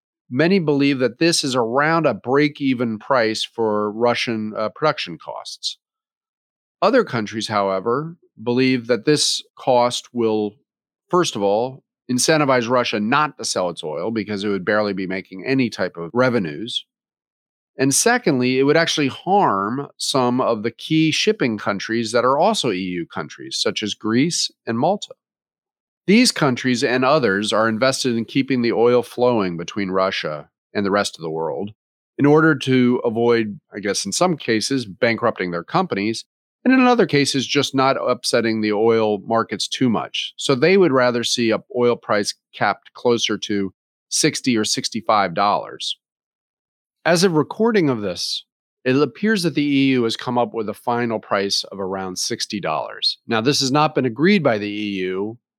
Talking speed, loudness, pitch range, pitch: 165 wpm, -19 LUFS, 110-145 Hz, 125 Hz